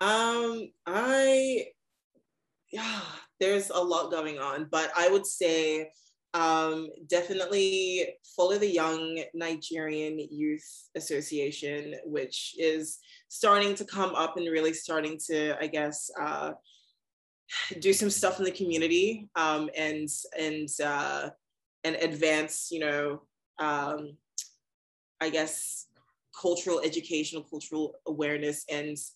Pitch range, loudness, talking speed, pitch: 155-185 Hz, -30 LUFS, 115 wpm, 160 Hz